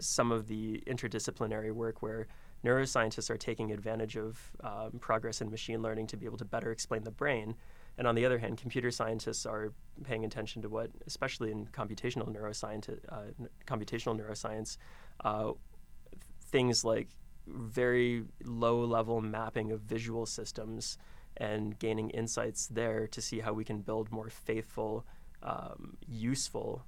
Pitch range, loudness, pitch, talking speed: 110-115 Hz, -36 LUFS, 110 Hz, 150 wpm